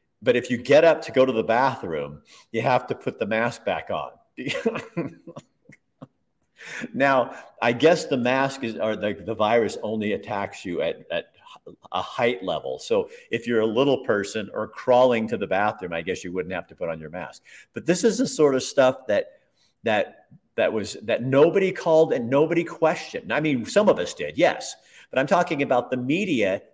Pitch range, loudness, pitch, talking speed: 110-165 Hz, -23 LUFS, 130 Hz, 195 wpm